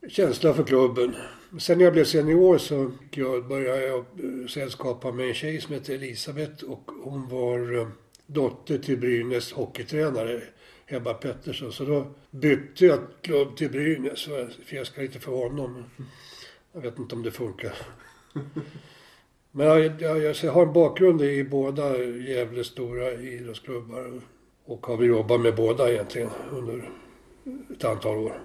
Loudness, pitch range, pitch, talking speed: -25 LUFS, 120-150 Hz, 135 Hz, 145 wpm